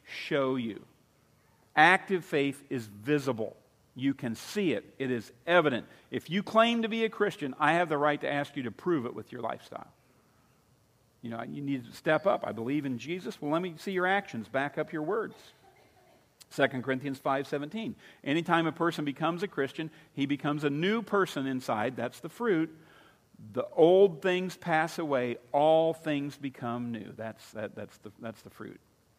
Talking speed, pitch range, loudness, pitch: 185 wpm, 130-170 Hz, -30 LUFS, 145 Hz